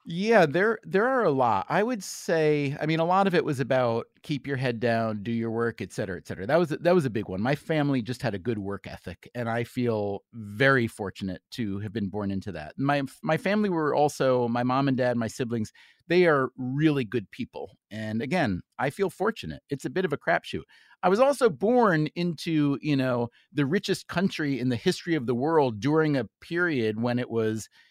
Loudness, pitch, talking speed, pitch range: -26 LUFS, 135 Hz, 225 wpm, 115-160 Hz